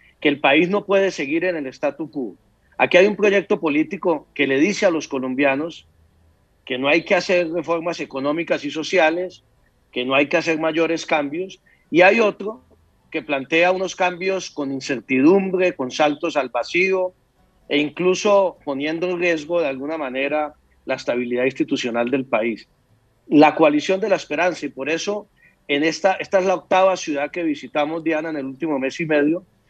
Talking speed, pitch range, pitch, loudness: 175 wpm, 140-180 Hz, 155 Hz, -20 LUFS